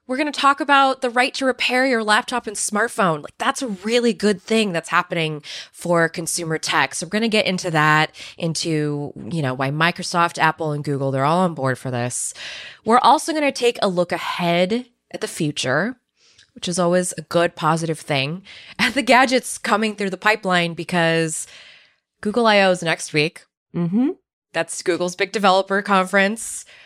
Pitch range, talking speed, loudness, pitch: 165-225 Hz, 180 wpm, -19 LUFS, 180 Hz